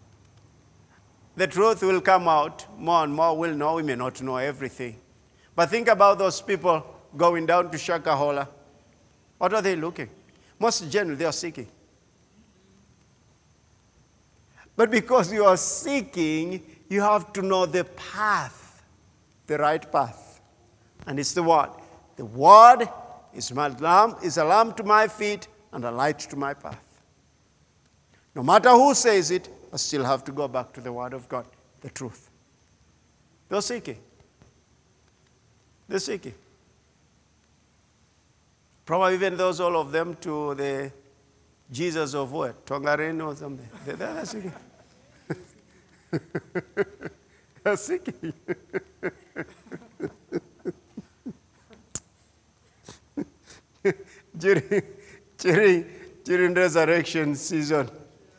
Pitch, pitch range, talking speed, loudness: 160 Hz, 135-190 Hz, 115 wpm, -23 LUFS